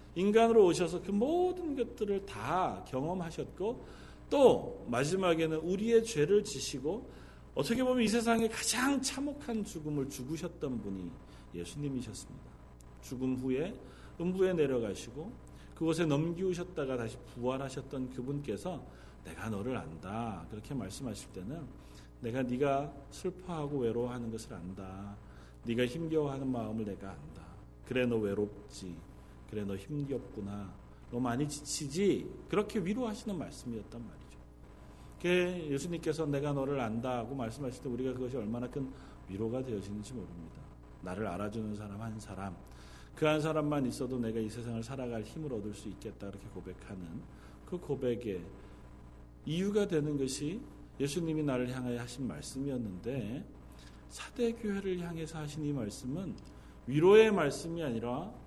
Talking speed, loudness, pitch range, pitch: 315 characters per minute, -35 LUFS, 100-160 Hz, 130 Hz